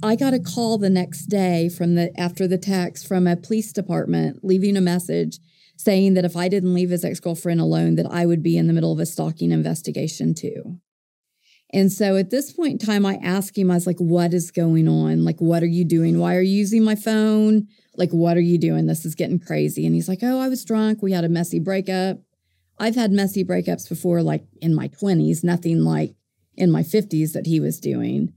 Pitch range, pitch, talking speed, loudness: 165-195 Hz, 175 Hz, 230 wpm, -20 LUFS